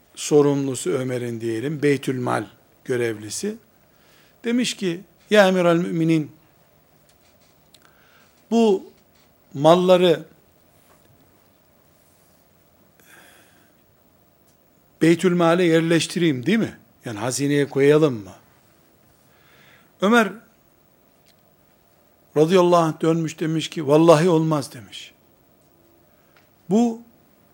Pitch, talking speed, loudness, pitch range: 155 Hz, 65 wpm, -20 LUFS, 125-175 Hz